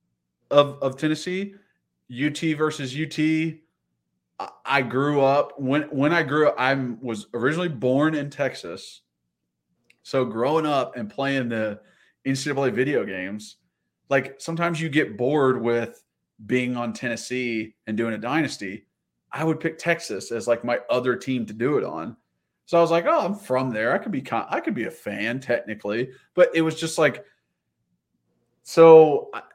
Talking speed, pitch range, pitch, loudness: 165 wpm, 110-155 Hz, 130 Hz, -23 LUFS